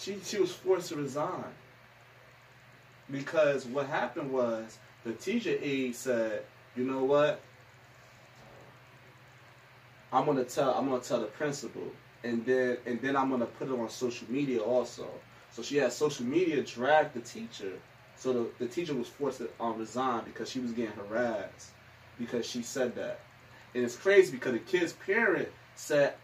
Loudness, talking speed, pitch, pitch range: -32 LUFS, 160 wpm, 130 Hz, 120-140 Hz